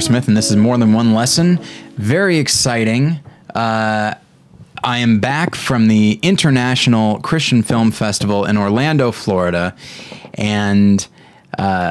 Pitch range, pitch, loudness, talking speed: 105-130 Hz, 115 Hz, -14 LUFS, 125 wpm